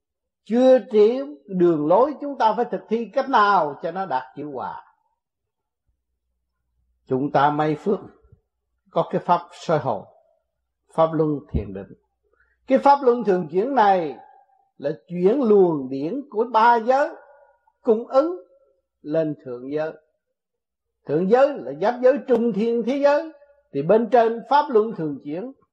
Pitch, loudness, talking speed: 225 Hz, -21 LUFS, 145 wpm